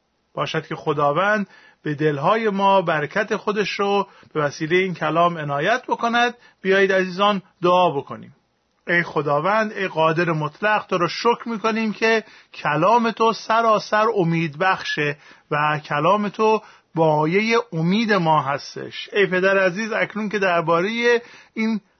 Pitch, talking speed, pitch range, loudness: 190 Hz, 130 wpm, 160-215 Hz, -20 LUFS